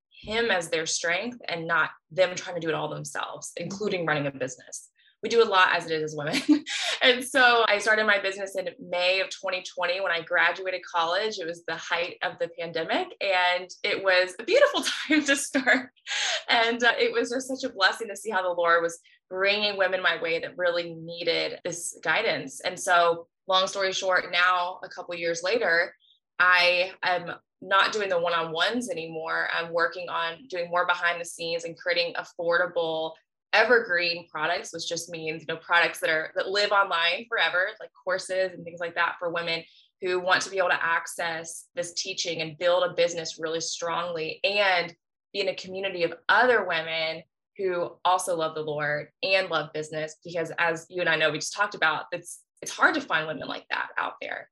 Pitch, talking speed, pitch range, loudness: 175 Hz, 200 wpm, 165-190 Hz, -25 LUFS